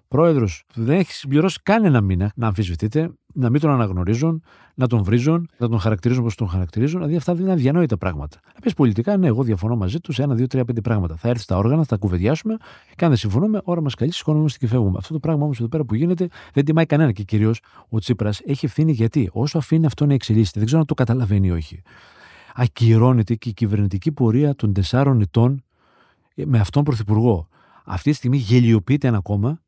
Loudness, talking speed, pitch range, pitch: -20 LUFS, 210 wpm, 110-155 Hz, 125 Hz